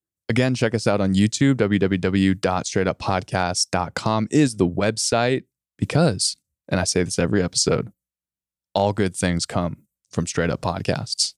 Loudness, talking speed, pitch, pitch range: -22 LUFS, 130 wpm, 95 Hz, 90-110 Hz